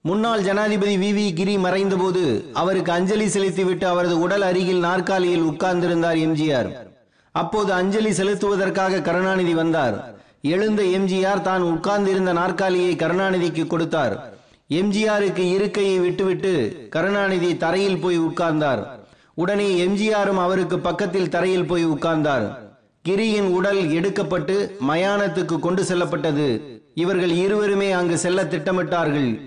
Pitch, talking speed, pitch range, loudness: 185 Hz, 105 wpm, 175-195 Hz, -21 LUFS